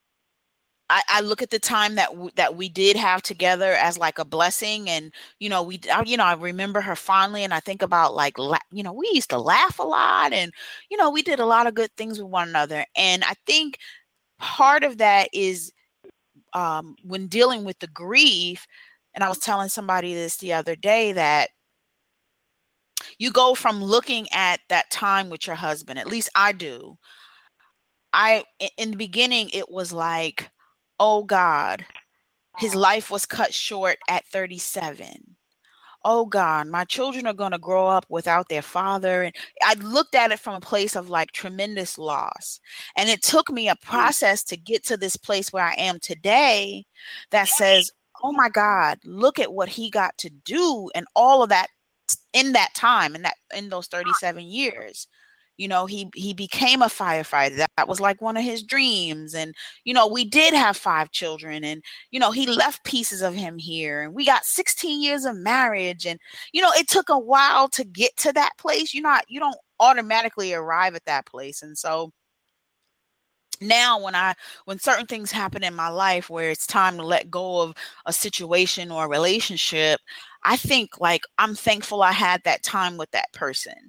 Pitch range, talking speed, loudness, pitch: 175-230 Hz, 190 wpm, -21 LUFS, 195 Hz